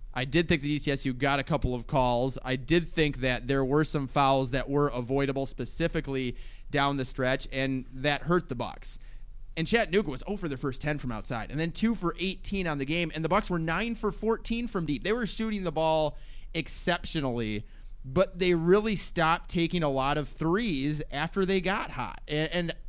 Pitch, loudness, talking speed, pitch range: 150 Hz, -29 LUFS, 205 wpm, 130-175 Hz